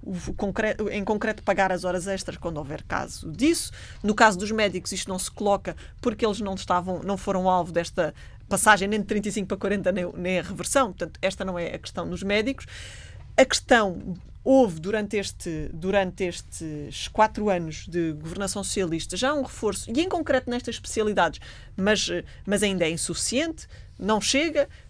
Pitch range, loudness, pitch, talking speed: 180-215 Hz, -25 LUFS, 200 Hz, 170 wpm